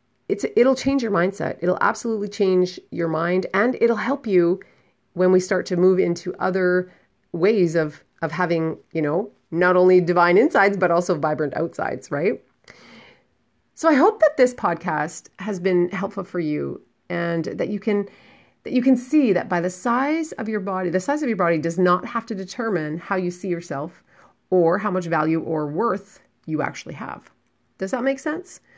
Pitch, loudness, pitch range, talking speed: 185 Hz, -21 LUFS, 175-220 Hz, 185 wpm